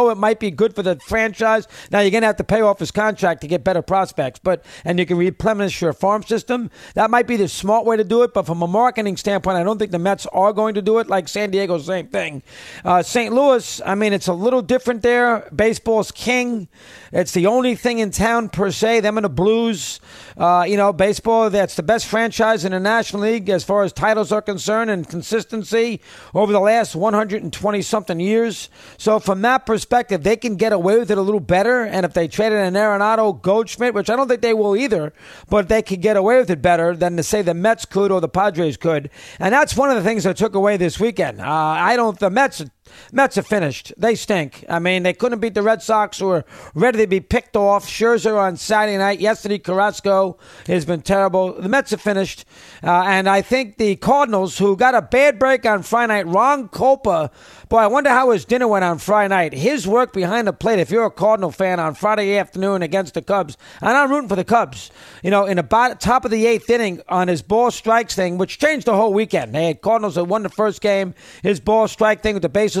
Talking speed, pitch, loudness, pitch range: 235 wpm, 205 Hz, -18 LUFS, 185-225 Hz